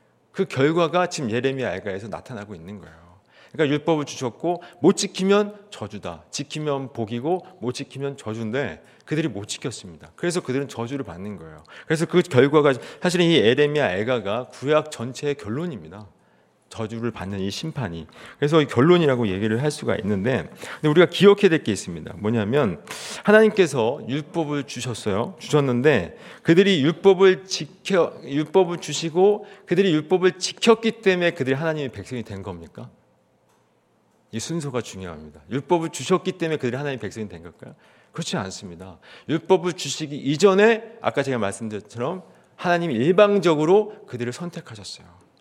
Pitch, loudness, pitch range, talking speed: 145 Hz, -22 LUFS, 115-175 Hz, 375 characters per minute